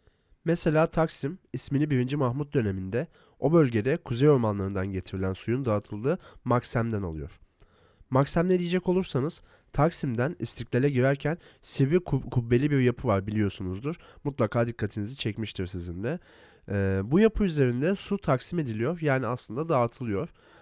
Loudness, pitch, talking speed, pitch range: -28 LUFS, 125 Hz, 130 wpm, 105-155 Hz